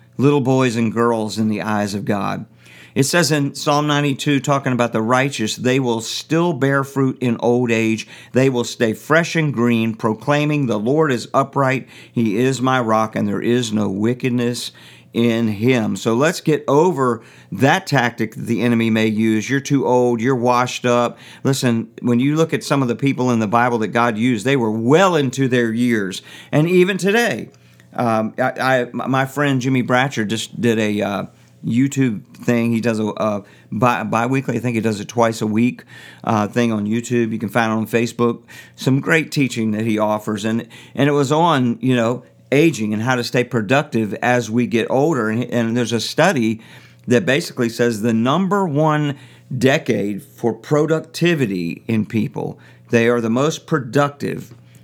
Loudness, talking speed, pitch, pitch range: -18 LUFS, 185 wpm, 120 Hz, 110-135 Hz